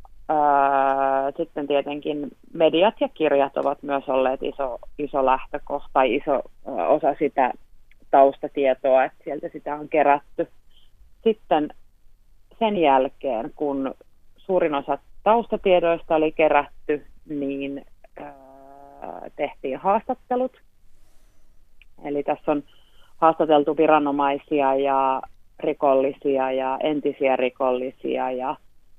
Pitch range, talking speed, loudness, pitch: 130-155 Hz, 90 wpm, -22 LUFS, 140 Hz